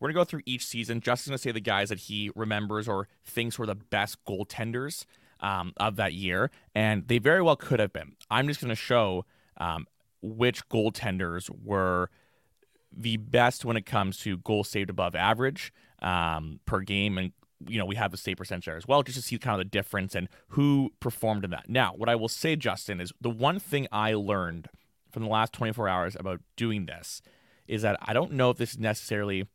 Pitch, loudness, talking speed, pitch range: 110 Hz, -29 LUFS, 215 wpm, 95-120 Hz